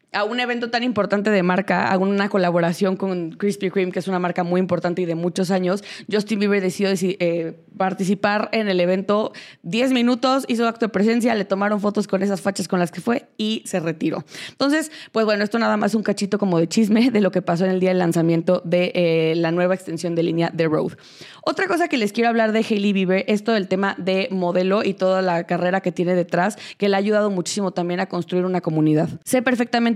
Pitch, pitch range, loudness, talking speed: 195 Hz, 180-215 Hz, -20 LUFS, 225 wpm